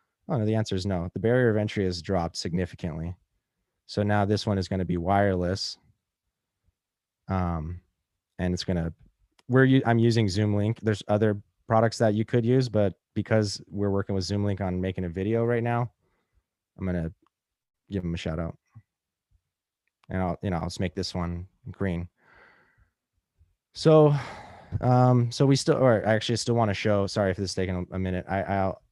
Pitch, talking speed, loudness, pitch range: 100 Hz, 190 wpm, -26 LUFS, 90-110 Hz